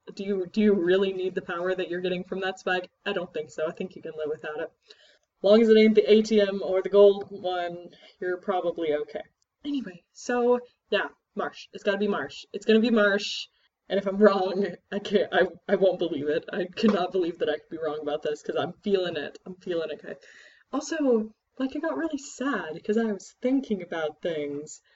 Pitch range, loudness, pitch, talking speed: 175-210 Hz, -26 LUFS, 190 Hz, 215 wpm